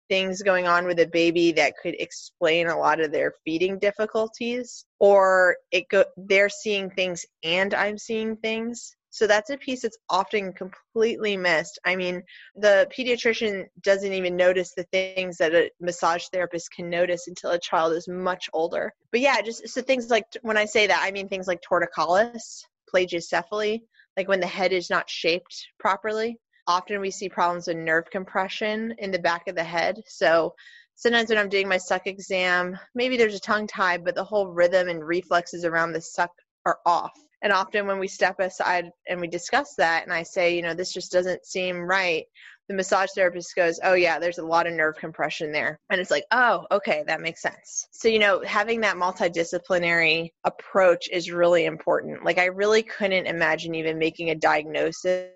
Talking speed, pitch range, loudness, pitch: 190 wpm, 175-210 Hz, -24 LUFS, 185 Hz